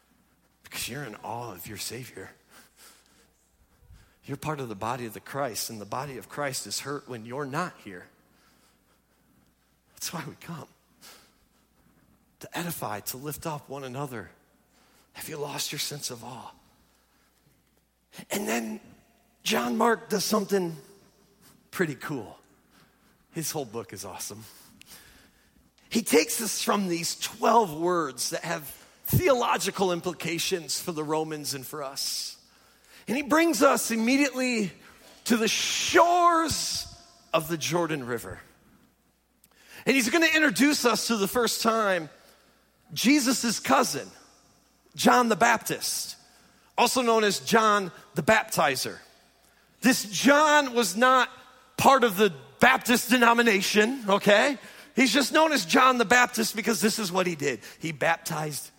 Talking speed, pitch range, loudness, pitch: 135 wpm, 145-235 Hz, -25 LUFS, 200 Hz